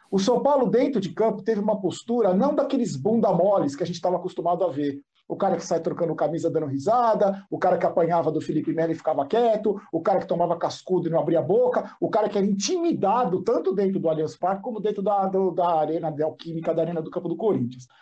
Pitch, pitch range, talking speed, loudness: 180 Hz, 165-215 Hz, 240 wpm, -24 LUFS